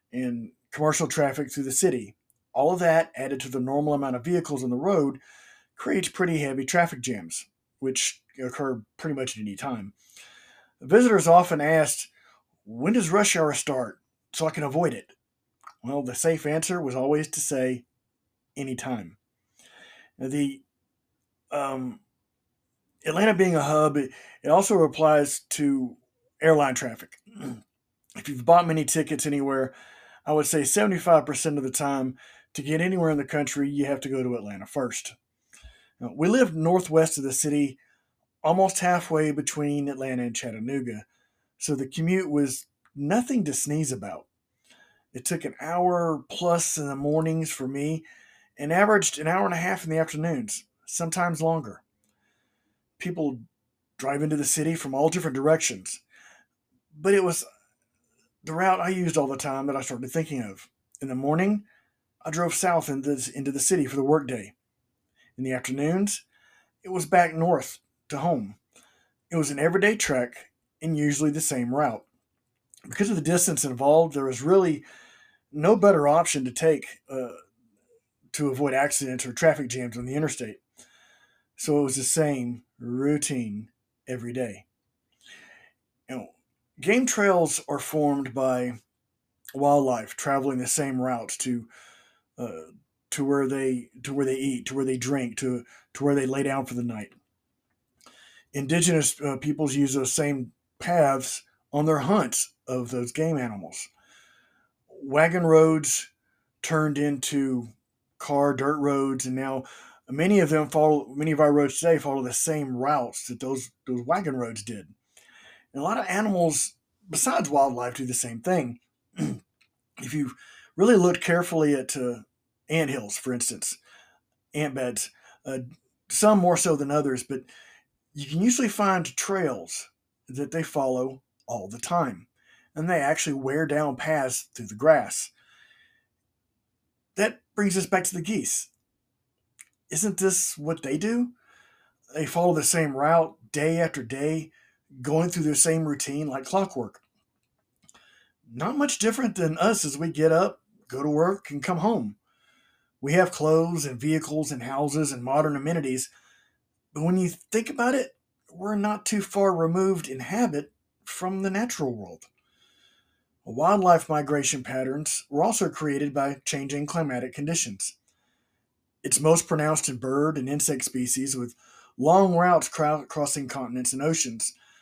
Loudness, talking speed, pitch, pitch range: -25 LUFS, 150 wpm, 145 Hz, 130-165 Hz